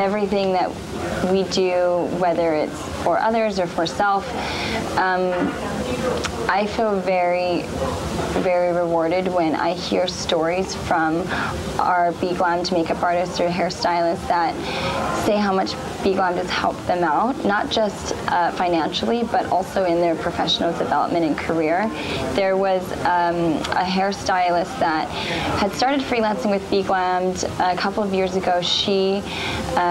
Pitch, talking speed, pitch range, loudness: 180 Hz, 140 wpm, 175-195 Hz, -21 LUFS